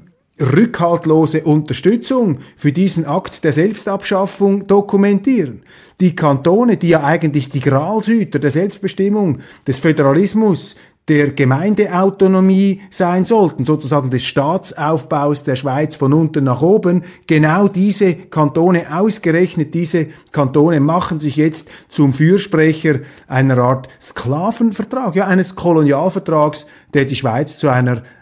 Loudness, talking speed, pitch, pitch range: -14 LUFS, 115 wpm, 165 Hz, 145-190 Hz